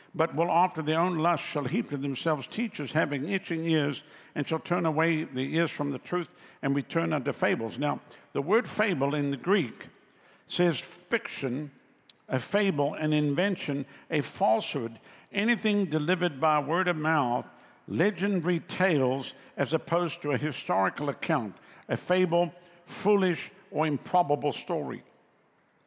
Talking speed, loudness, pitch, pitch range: 145 wpm, -29 LUFS, 160 Hz, 145-180 Hz